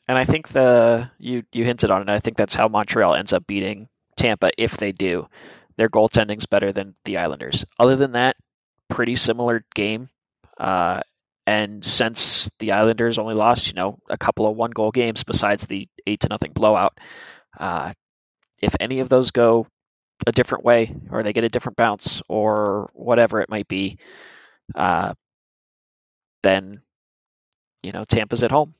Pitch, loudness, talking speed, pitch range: 115 Hz, -20 LUFS, 165 wpm, 105-120 Hz